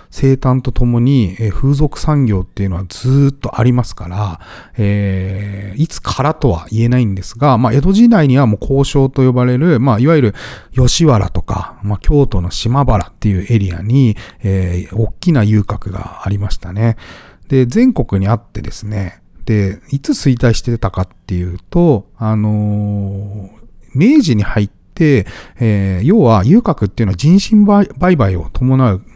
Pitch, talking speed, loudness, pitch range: 115 Hz, 305 characters per minute, -14 LUFS, 100-135 Hz